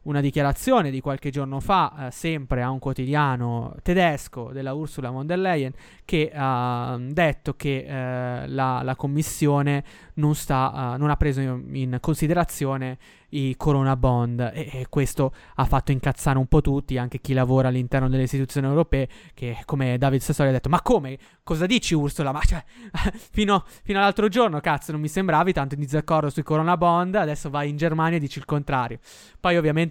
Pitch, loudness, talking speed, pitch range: 140 Hz, -24 LUFS, 180 wpm, 130-160 Hz